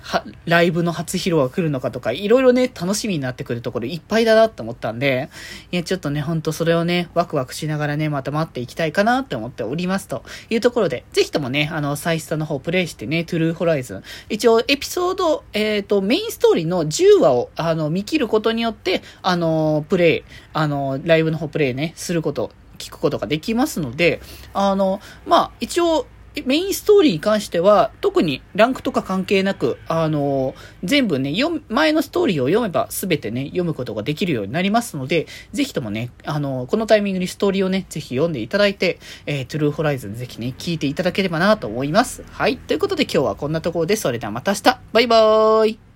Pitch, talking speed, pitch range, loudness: 175 Hz, 455 characters per minute, 155-220 Hz, -20 LUFS